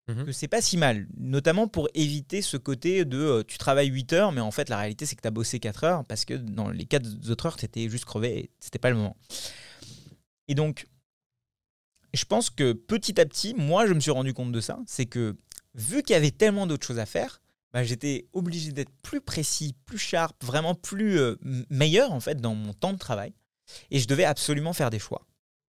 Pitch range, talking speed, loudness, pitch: 120-160 Hz, 225 wpm, -27 LUFS, 140 Hz